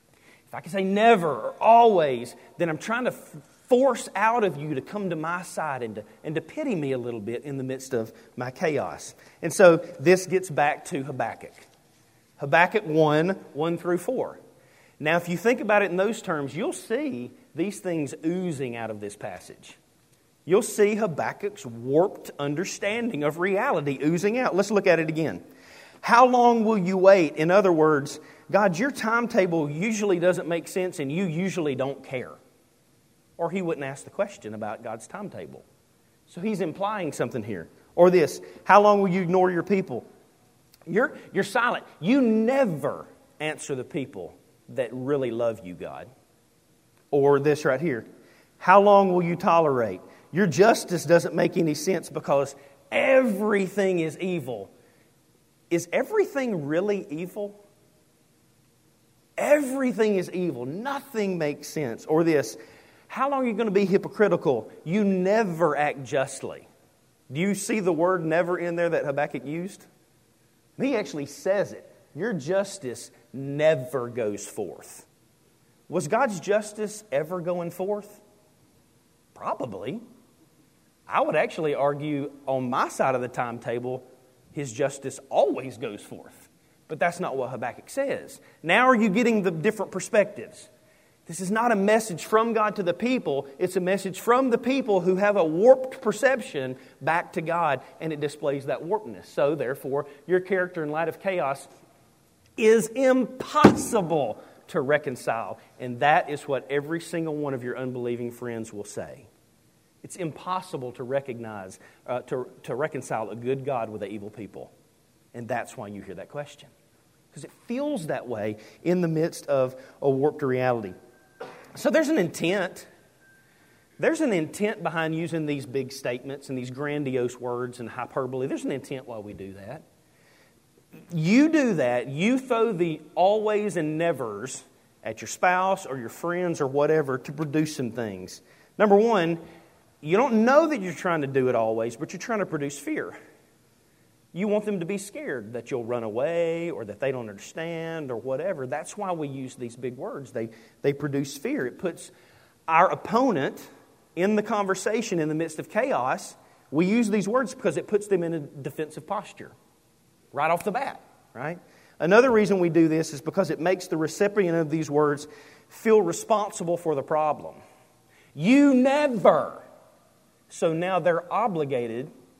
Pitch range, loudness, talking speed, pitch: 140-200 Hz, -25 LUFS, 165 wpm, 165 Hz